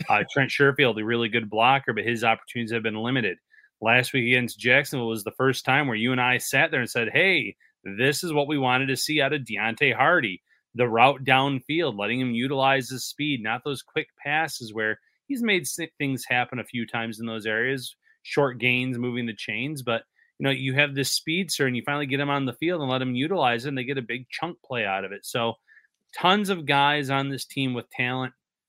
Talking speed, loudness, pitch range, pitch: 230 wpm, -24 LUFS, 120-145 Hz, 130 Hz